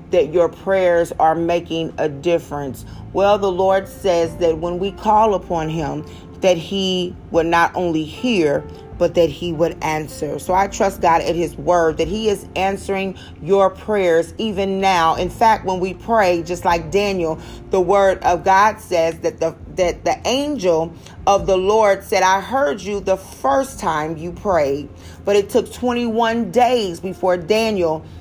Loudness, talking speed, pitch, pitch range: -18 LUFS, 170 wpm, 185 Hz, 165-200 Hz